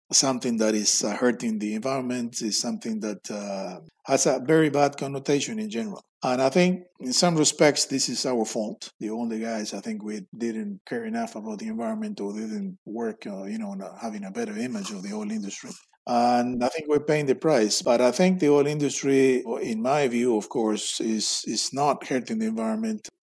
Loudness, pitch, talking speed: -25 LUFS, 145 Hz, 200 wpm